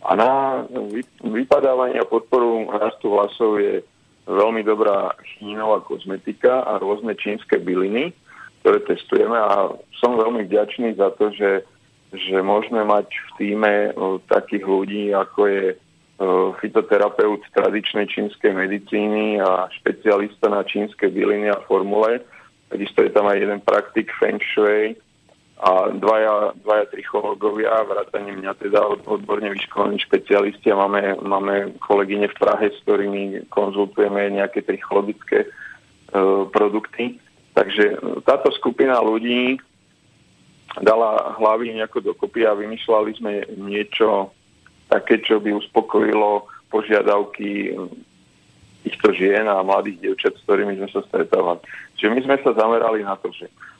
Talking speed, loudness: 125 wpm, -20 LUFS